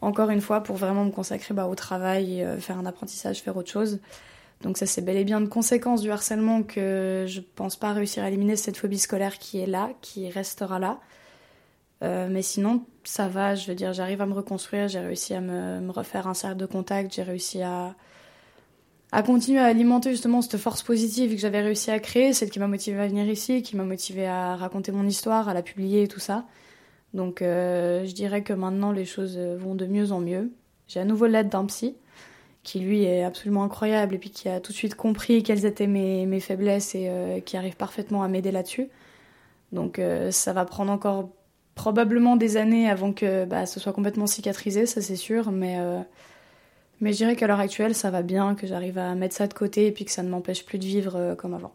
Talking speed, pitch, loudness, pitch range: 225 wpm, 200 Hz, -26 LUFS, 185-215 Hz